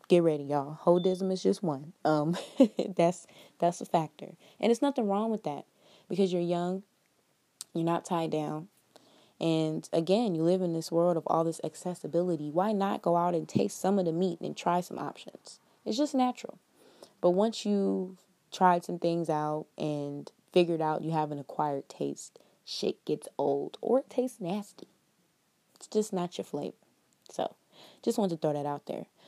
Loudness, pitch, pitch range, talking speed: -30 LUFS, 175 Hz, 160-195 Hz, 180 wpm